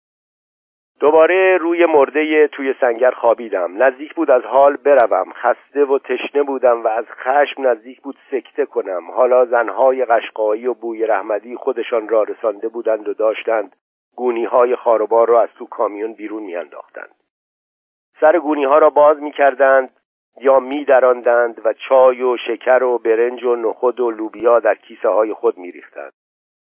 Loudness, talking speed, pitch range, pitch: -16 LUFS, 155 wpm, 120-155 Hz, 130 Hz